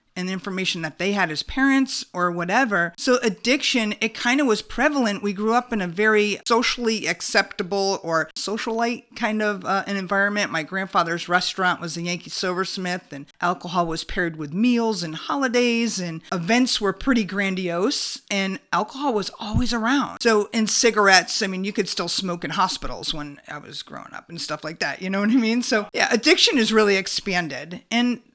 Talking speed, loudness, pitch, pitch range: 190 wpm, -22 LUFS, 200 Hz, 180-230 Hz